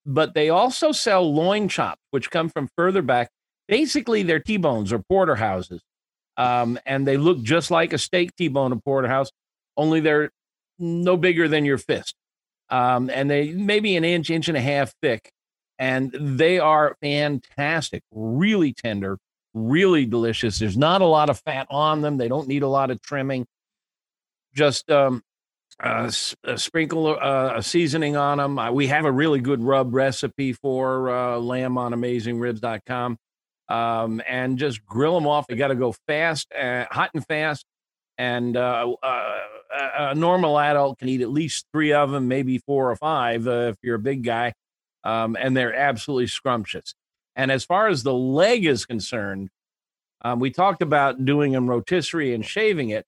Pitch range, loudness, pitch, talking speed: 125-155 Hz, -22 LUFS, 140 Hz, 175 wpm